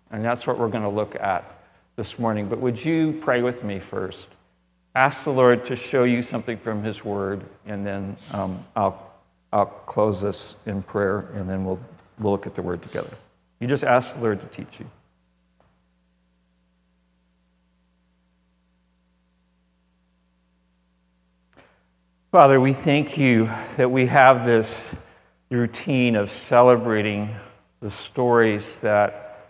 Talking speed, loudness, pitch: 135 wpm, -22 LUFS, 105 Hz